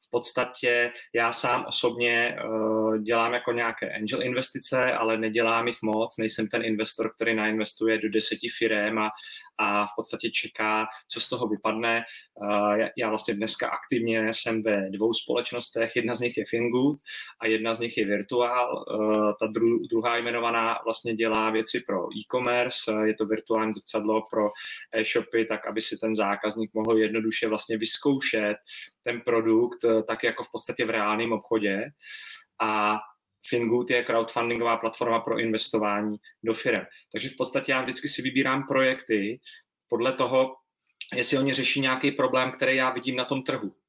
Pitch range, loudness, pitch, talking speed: 110-120 Hz, -26 LUFS, 115 Hz, 150 wpm